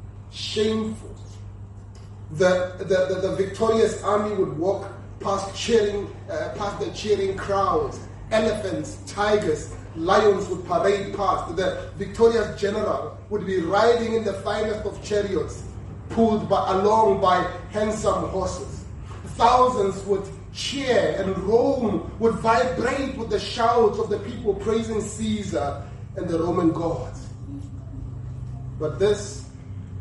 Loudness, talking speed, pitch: -23 LUFS, 120 wpm, 195 Hz